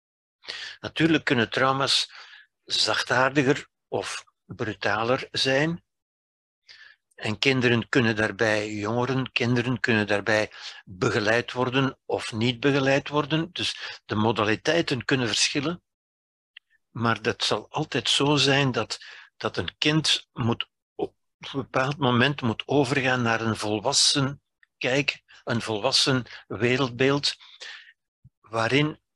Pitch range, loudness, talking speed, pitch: 115-140 Hz, -24 LUFS, 105 wpm, 130 Hz